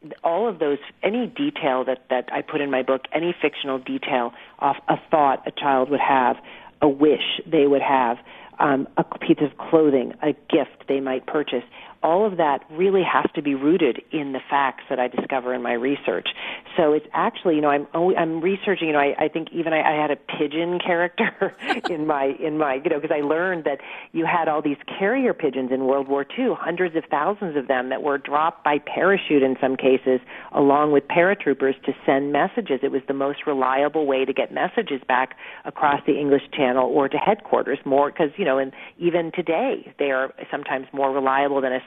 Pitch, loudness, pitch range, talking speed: 145 Hz, -22 LUFS, 135-165 Hz, 210 wpm